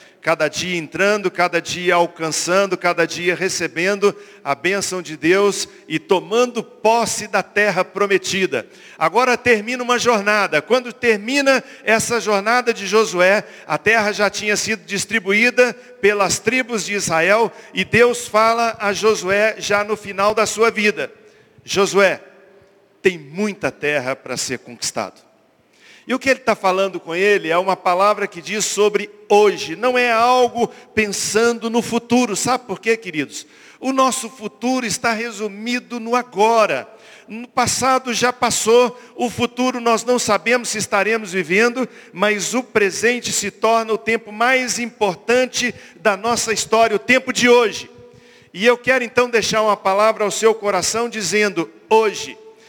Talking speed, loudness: 145 wpm, -17 LUFS